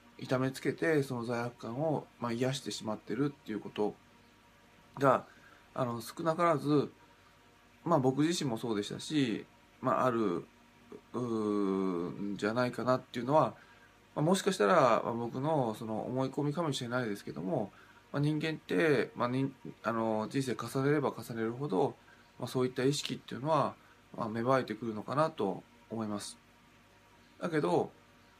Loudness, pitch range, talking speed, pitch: -33 LUFS, 110-140 Hz, 290 characters per minute, 125 Hz